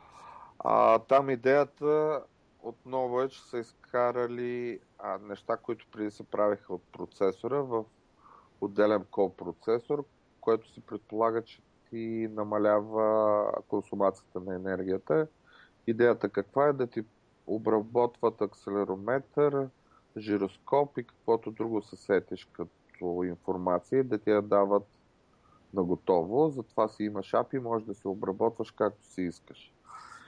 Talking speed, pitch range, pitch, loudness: 120 wpm, 100-120 Hz, 110 Hz, -30 LUFS